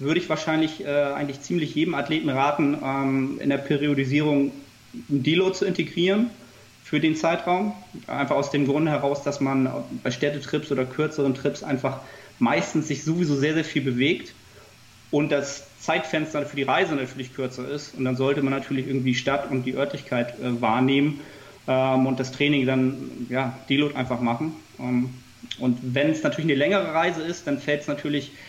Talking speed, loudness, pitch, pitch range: 175 wpm, -24 LUFS, 140 Hz, 130-150 Hz